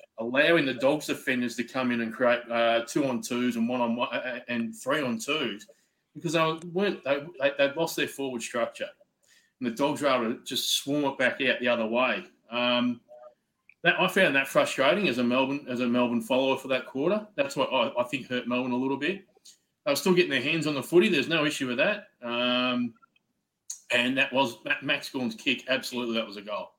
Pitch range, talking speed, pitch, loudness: 120-165 Hz, 215 wpm, 130 Hz, -27 LUFS